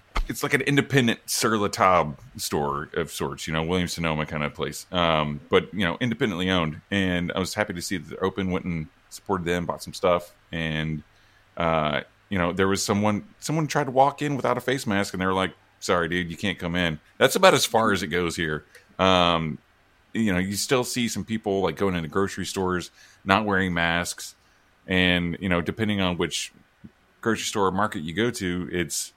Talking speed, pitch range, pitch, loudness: 210 wpm, 85-100 Hz, 95 Hz, -25 LUFS